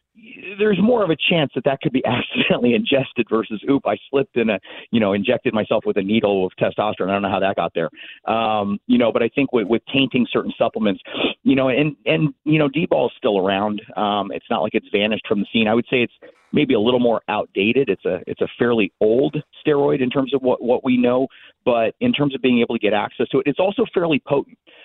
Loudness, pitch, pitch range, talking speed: -19 LUFS, 130 Hz, 110-150 Hz, 245 wpm